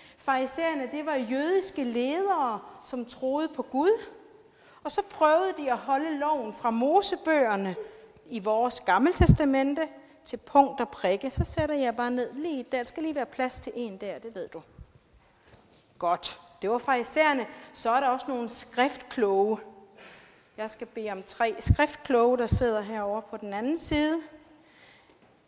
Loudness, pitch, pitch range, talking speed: -27 LUFS, 260 Hz, 230-310 Hz, 155 wpm